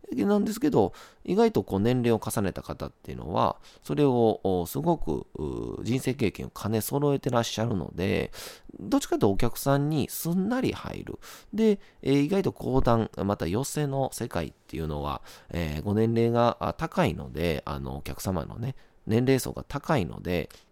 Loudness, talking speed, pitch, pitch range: -28 LUFS, 325 characters per minute, 120 Hz, 95-145 Hz